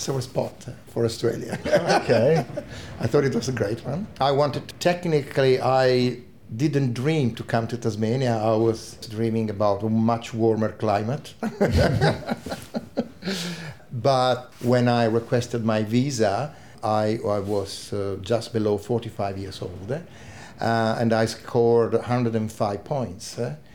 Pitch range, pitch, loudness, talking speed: 110-130 Hz, 115 Hz, -24 LUFS, 135 wpm